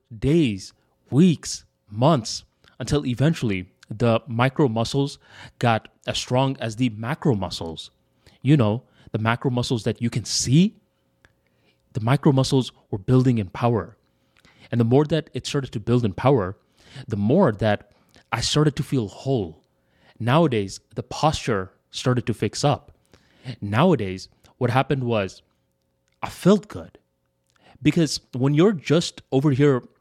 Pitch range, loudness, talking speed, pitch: 105-140 Hz, -22 LUFS, 140 wpm, 125 Hz